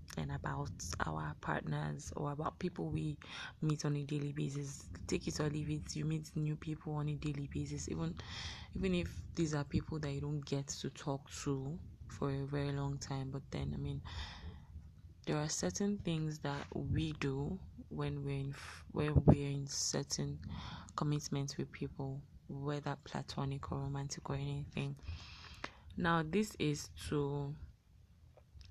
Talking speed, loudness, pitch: 155 wpm, -40 LUFS, 140 Hz